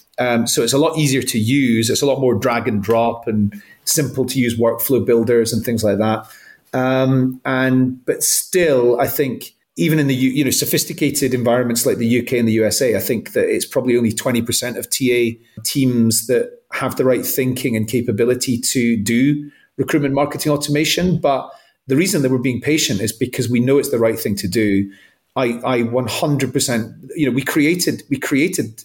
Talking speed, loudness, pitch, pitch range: 200 wpm, -17 LUFS, 125 Hz, 115-140 Hz